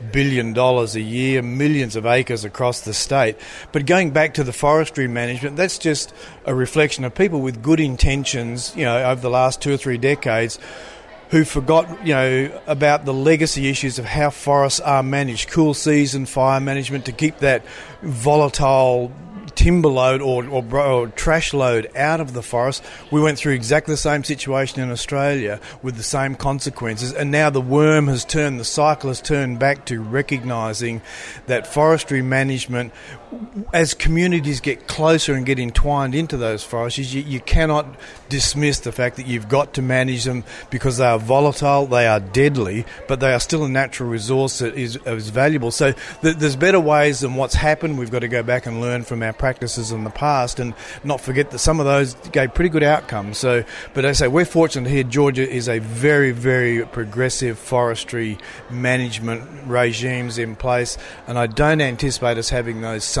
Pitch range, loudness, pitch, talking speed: 120-145 Hz, -19 LUFS, 135 Hz, 185 wpm